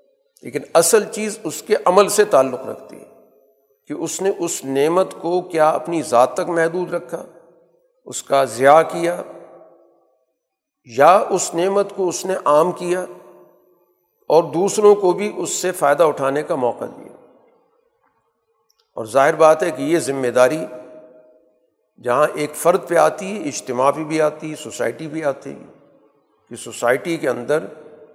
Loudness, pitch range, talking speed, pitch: -18 LUFS, 145-195 Hz, 150 wpm, 165 Hz